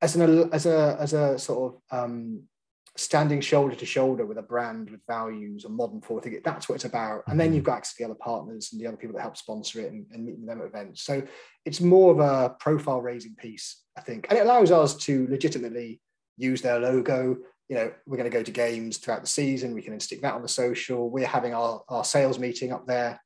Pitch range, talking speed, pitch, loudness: 120-150 Hz, 240 wpm, 130 Hz, -26 LUFS